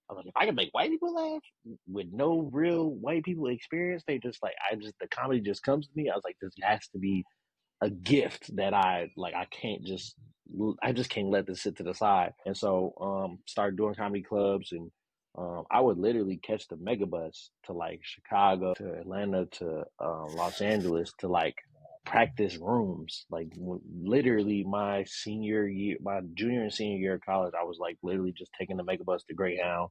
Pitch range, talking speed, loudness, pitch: 90-120 Hz, 205 wpm, -31 LUFS, 100 Hz